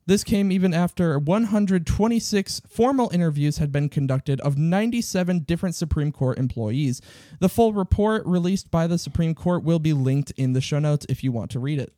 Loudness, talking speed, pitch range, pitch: -23 LUFS, 185 wpm, 140-190 Hz, 165 Hz